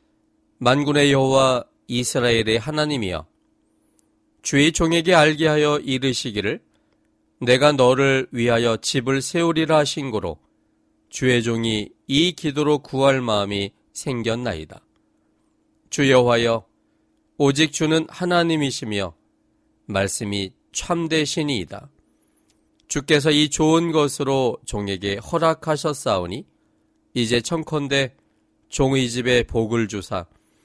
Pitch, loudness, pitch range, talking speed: 135 Hz, -20 LUFS, 115-155 Hz, 235 characters per minute